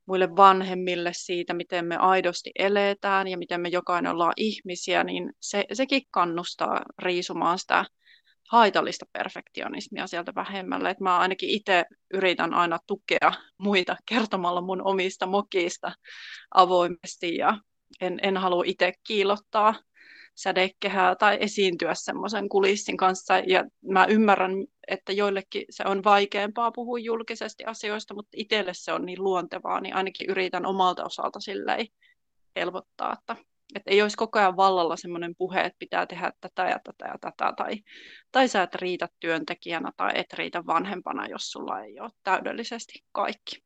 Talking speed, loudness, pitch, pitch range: 145 wpm, -26 LUFS, 190 Hz, 180-205 Hz